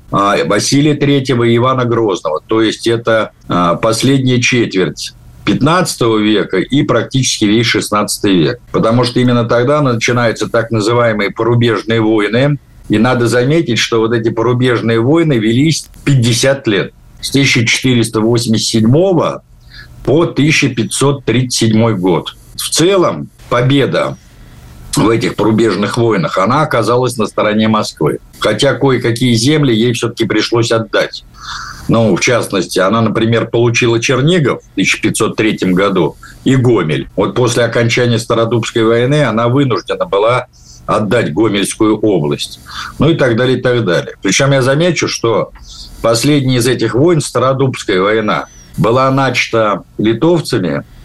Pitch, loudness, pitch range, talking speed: 120 Hz, -12 LUFS, 110-130 Hz, 120 wpm